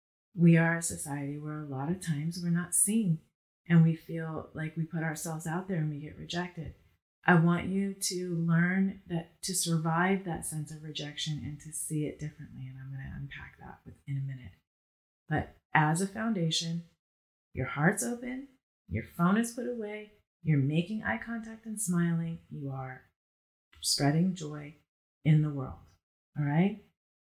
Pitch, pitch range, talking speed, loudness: 165 Hz, 145-180 Hz, 170 wpm, -31 LUFS